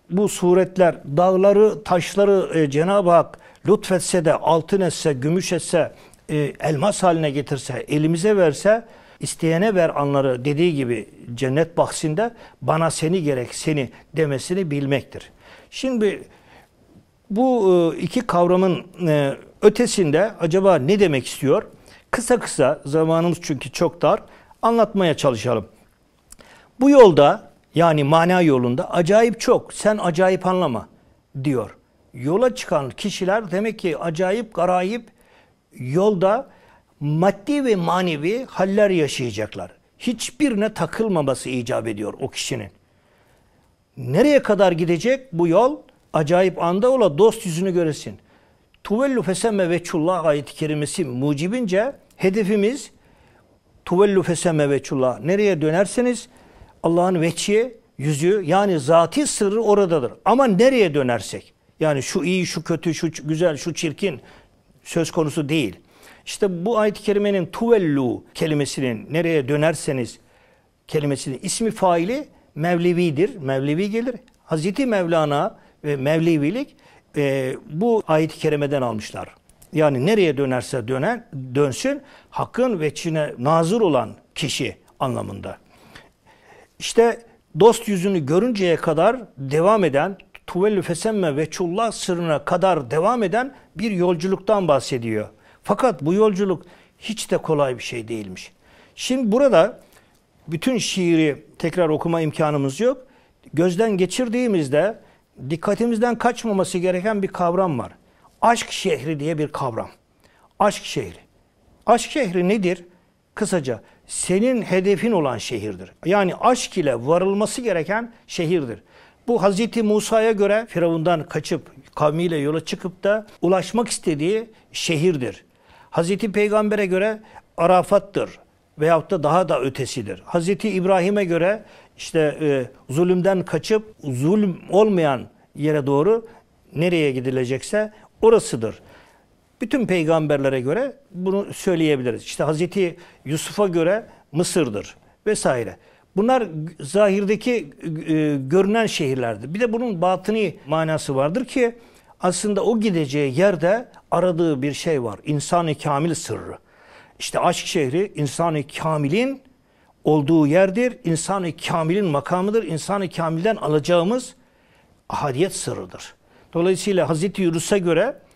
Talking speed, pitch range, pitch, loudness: 110 wpm, 150-205 Hz, 175 Hz, -20 LUFS